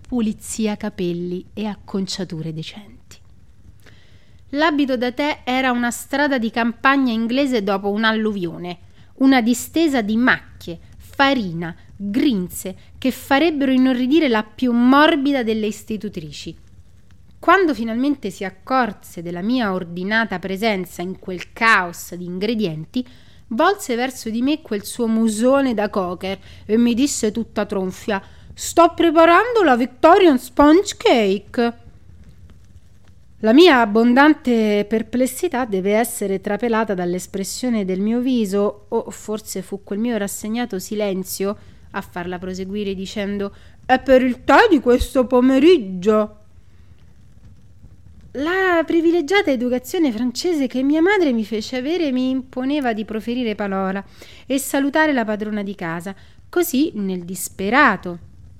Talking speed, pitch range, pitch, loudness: 120 wpm, 190-260 Hz, 220 Hz, -18 LUFS